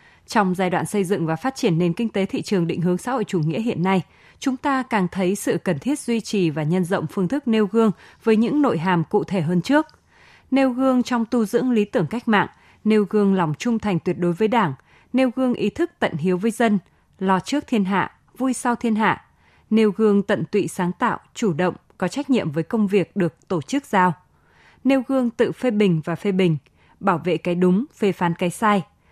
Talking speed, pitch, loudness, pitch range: 235 wpm, 205 Hz, -21 LUFS, 180-235 Hz